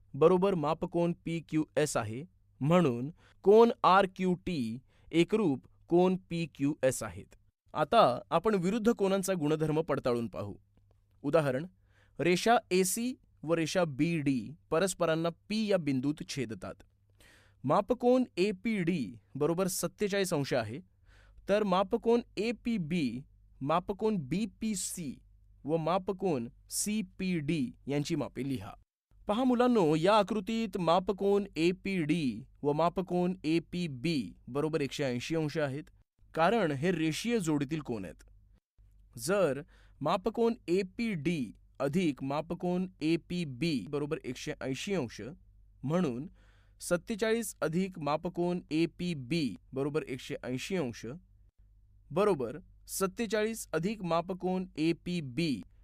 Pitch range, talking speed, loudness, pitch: 125-190 Hz, 125 wpm, -31 LUFS, 165 Hz